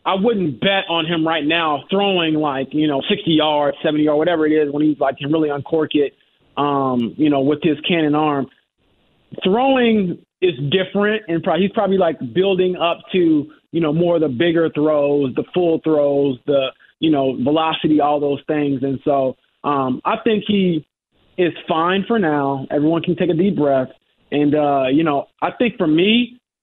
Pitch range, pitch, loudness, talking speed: 145-180 Hz, 155 Hz, -18 LUFS, 190 wpm